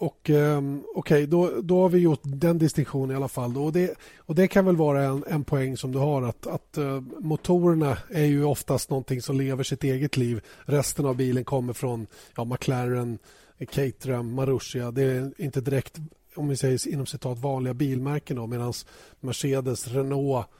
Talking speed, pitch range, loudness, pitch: 185 wpm, 130-150 Hz, -26 LUFS, 135 Hz